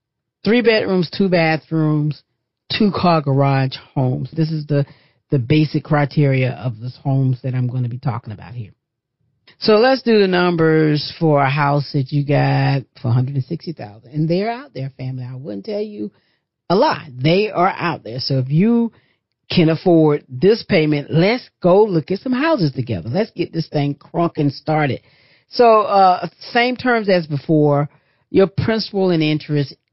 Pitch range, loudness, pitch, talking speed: 135-180 Hz, -17 LUFS, 150 Hz, 165 wpm